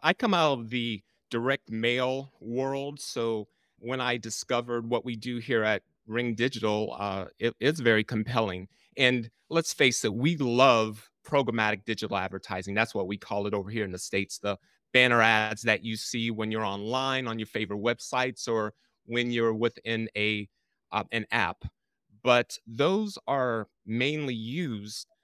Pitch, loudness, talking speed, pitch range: 115 Hz, -28 LUFS, 160 wpm, 110-125 Hz